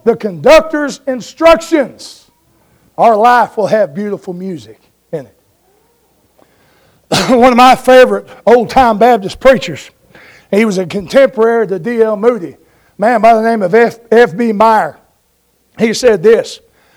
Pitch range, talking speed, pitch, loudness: 215-260 Hz, 130 wpm, 230 Hz, -10 LUFS